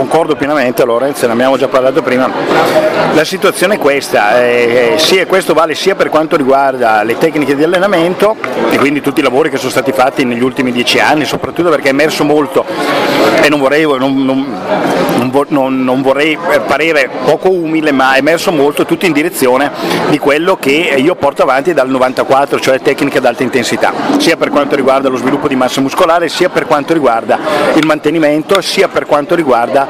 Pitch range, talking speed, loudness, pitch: 130-155 Hz, 190 wpm, -10 LUFS, 140 Hz